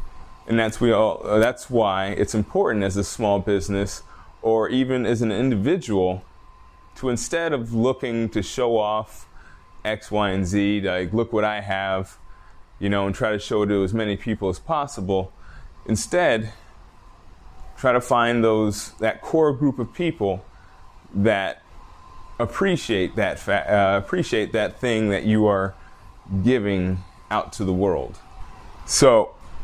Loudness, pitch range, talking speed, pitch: -22 LUFS, 95-115 Hz, 150 wpm, 105 Hz